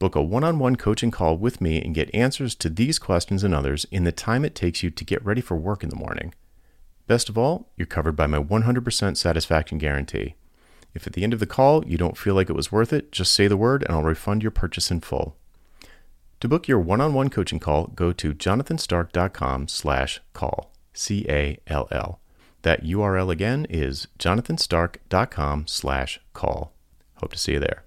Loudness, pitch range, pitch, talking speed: -23 LUFS, 80-110 Hz, 90 Hz, 190 wpm